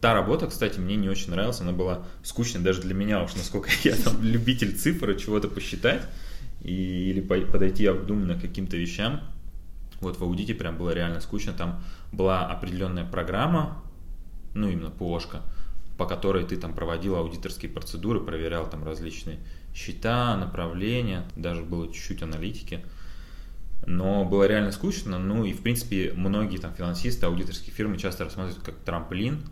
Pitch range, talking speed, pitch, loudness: 85-100 Hz, 150 wpm, 95 Hz, -28 LUFS